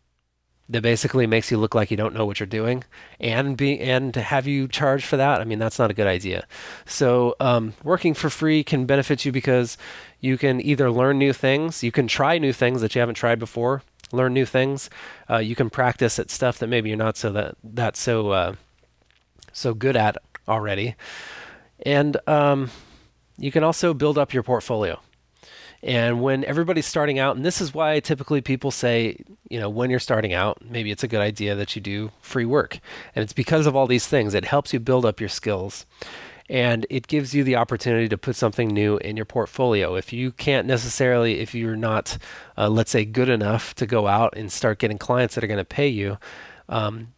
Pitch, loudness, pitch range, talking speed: 120 Hz, -22 LUFS, 110-135 Hz, 210 wpm